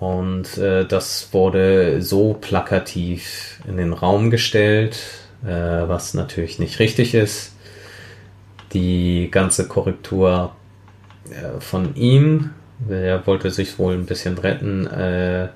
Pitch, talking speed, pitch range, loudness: 95 Hz, 115 wpm, 90-105 Hz, -19 LUFS